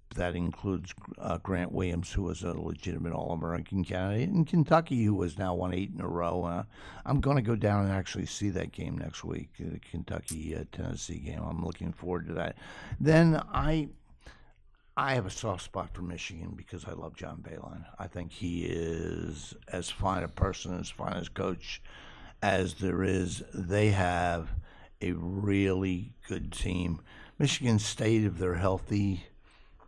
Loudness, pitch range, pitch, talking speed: -32 LUFS, 85-100 Hz, 95 Hz, 165 wpm